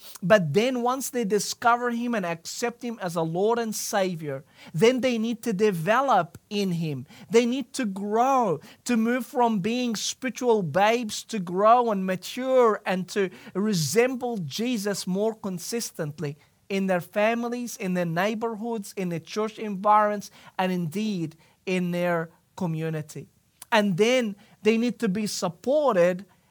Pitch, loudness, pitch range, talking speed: 210 Hz, -25 LUFS, 185-235 Hz, 145 wpm